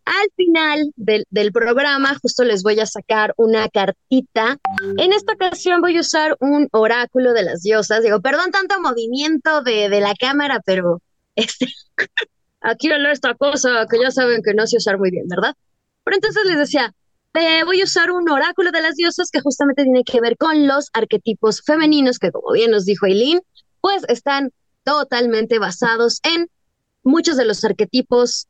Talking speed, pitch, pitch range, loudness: 180 wpm, 255 Hz, 225-315 Hz, -17 LUFS